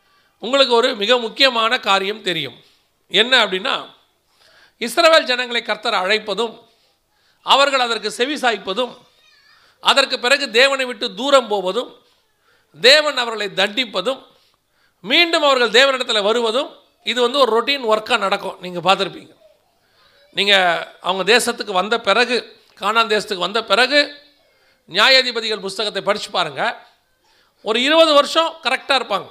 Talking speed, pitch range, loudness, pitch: 110 wpm, 210-275 Hz, -16 LUFS, 240 Hz